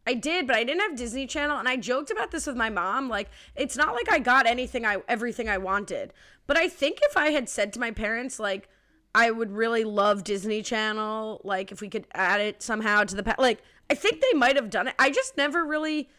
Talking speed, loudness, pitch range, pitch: 245 wpm, -25 LUFS, 215-285 Hz, 240 Hz